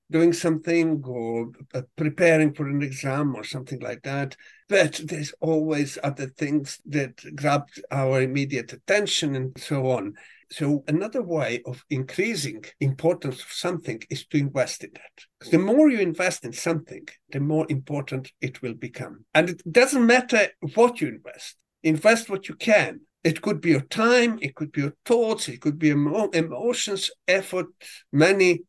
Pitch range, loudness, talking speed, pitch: 140-180 Hz, -24 LUFS, 160 wpm, 155 Hz